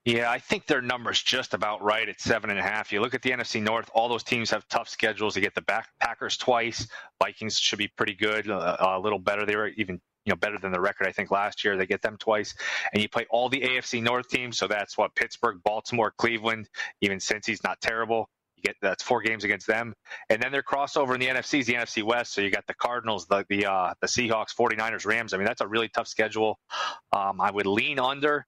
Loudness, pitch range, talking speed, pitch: -27 LUFS, 105-120 Hz, 250 wpm, 115 Hz